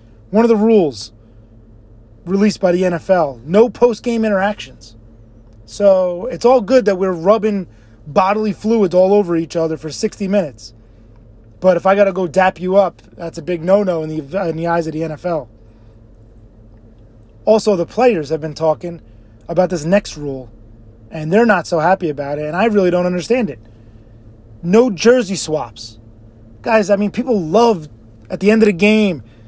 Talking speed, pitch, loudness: 175 wpm, 170 Hz, -15 LUFS